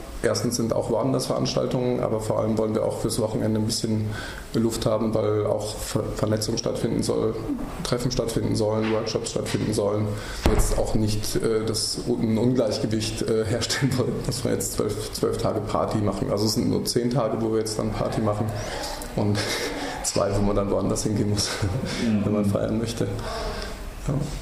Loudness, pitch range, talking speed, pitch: -25 LUFS, 105-115 Hz, 170 wpm, 110 Hz